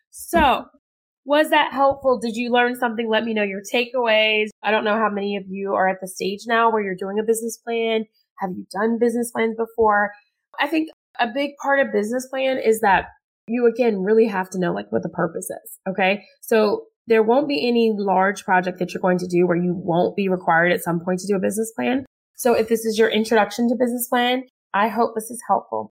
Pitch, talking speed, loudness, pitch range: 225 Hz, 225 wpm, -21 LUFS, 195-245 Hz